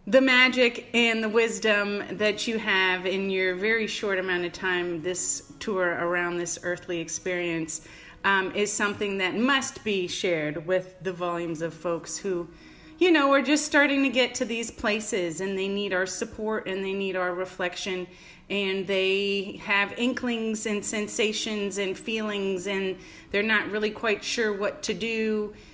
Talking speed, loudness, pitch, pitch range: 165 wpm, -26 LUFS, 200 Hz, 185-220 Hz